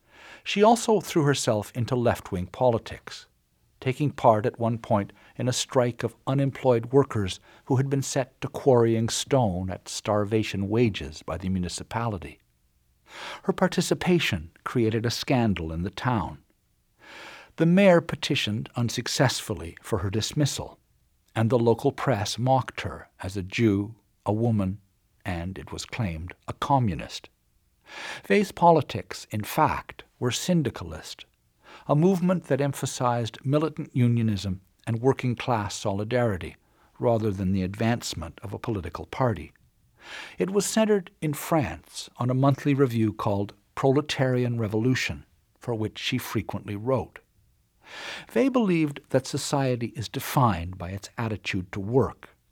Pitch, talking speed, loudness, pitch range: 115 Hz, 130 wpm, -26 LUFS, 100-135 Hz